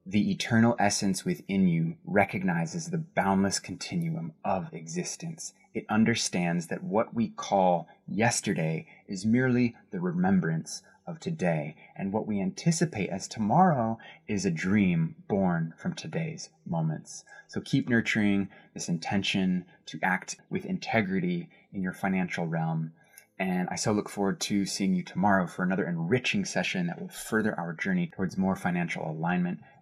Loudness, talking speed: -29 LUFS, 145 wpm